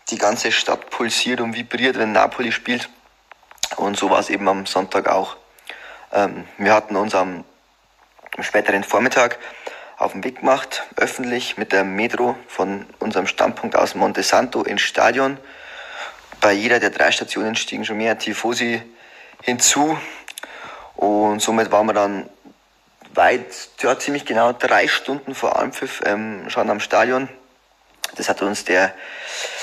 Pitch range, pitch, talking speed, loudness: 100-130 Hz, 115 Hz, 145 wpm, -19 LUFS